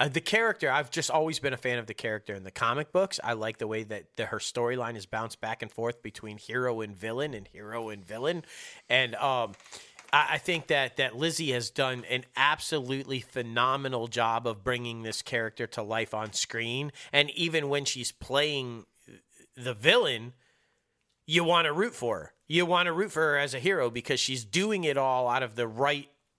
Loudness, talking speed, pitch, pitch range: -29 LUFS, 205 wpm, 125 Hz, 115-150 Hz